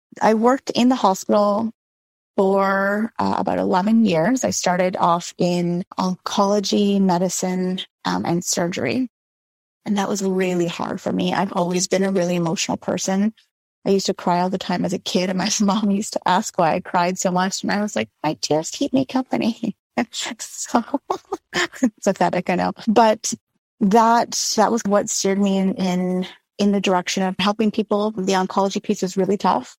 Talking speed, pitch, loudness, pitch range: 180 wpm, 195 Hz, -20 LUFS, 185-220 Hz